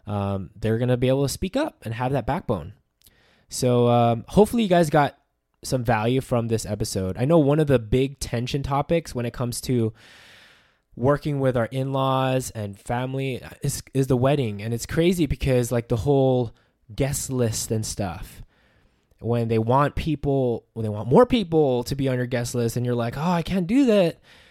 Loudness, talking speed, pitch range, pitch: -23 LUFS, 195 wpm, 115-140 Hz, 125 Hz